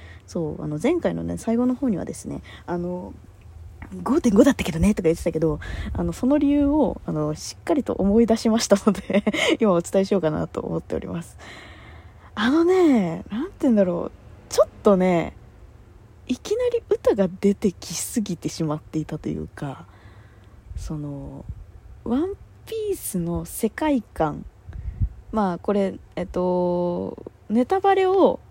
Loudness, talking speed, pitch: -23 LUFS, 280 characters per minute, 180 Hz